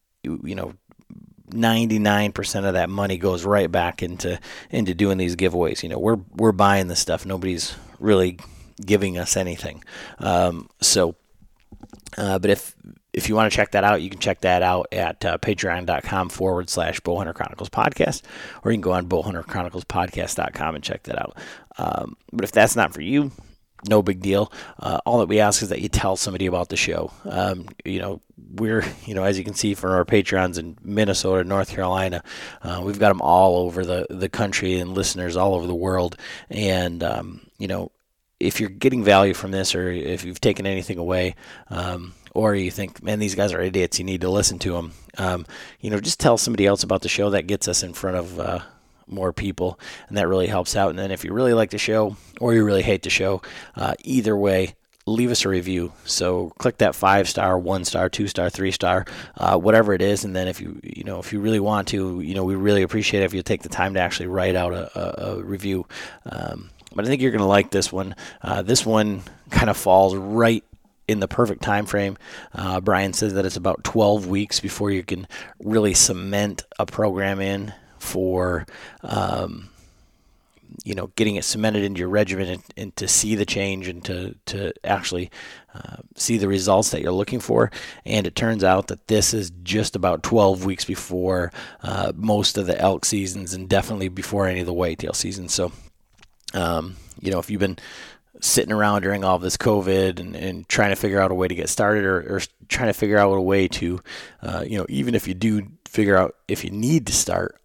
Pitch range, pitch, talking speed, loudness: 90-105 Hz, 95 Hz, 210 wpm, -22 LUFS